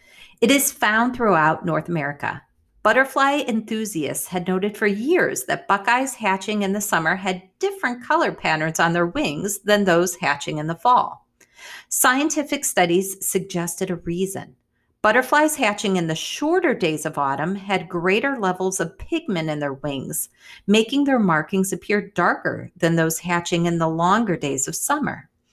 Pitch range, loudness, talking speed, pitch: 170-235 Hz, -21 LUFS, 155 wpm, 190 Hz